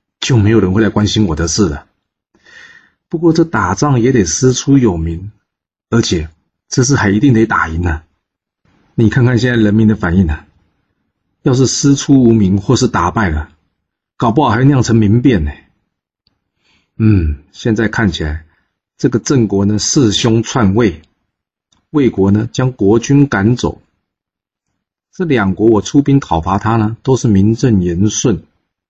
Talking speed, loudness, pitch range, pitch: 220 characters per minute, -12 LUFS, 95-125 Hz, 110 Hz